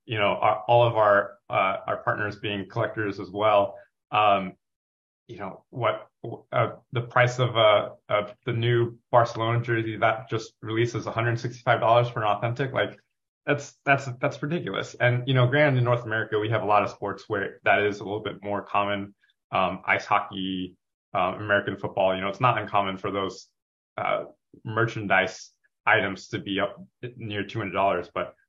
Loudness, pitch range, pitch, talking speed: -25 LUFS, 100-120 Hz, 110 Hz, 175 wpm